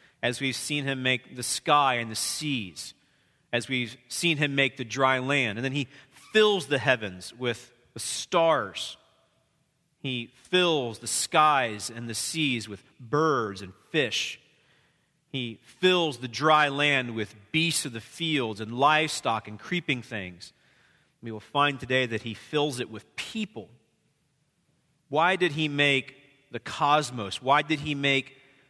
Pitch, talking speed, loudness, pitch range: 135 Hz, 155 wpm, -26 LUFS, 120-150 Hz